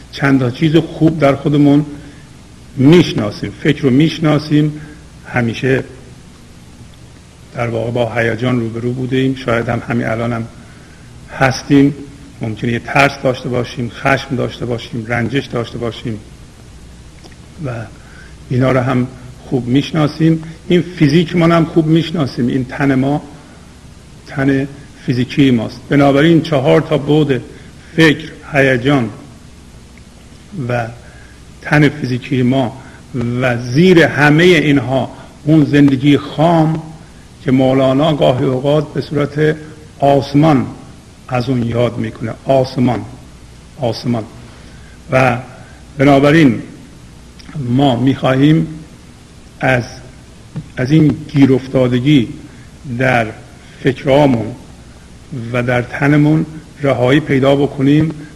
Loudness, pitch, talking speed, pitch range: -14 LUFS, 135 Hz, 105 wpm, 125-150 Hz